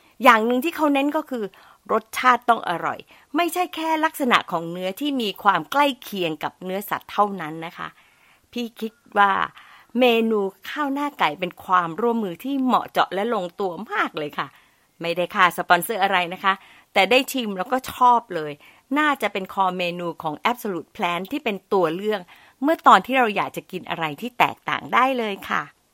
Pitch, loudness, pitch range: 210 Hz, -22 LUFS, 180-255 Hz